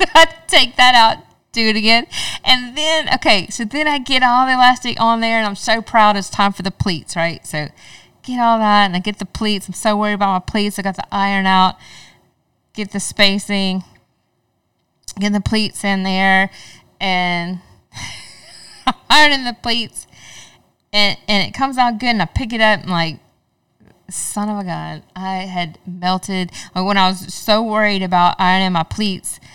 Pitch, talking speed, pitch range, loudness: 205 Hz, 180 wpm, 185-230 Hz, -15 LUFS